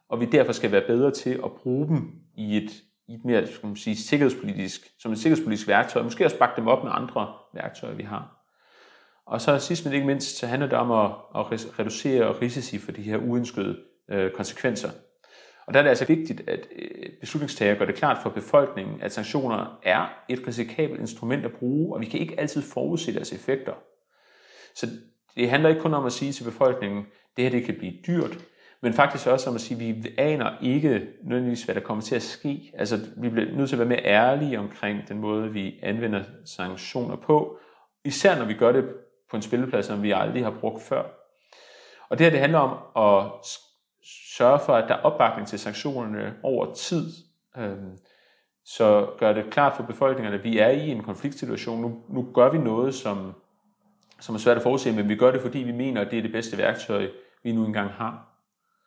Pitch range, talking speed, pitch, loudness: 105-140 Hz, 205 wpm, 120 Hz, -25 LUFS